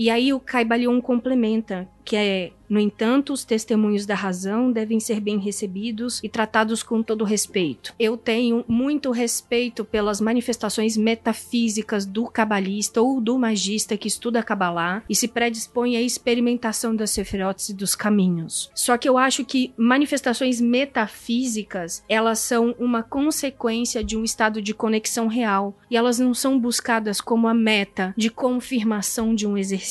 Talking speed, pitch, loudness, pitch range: 155 wpm, 225 Hz, -22 LUFS, 215-240 Hz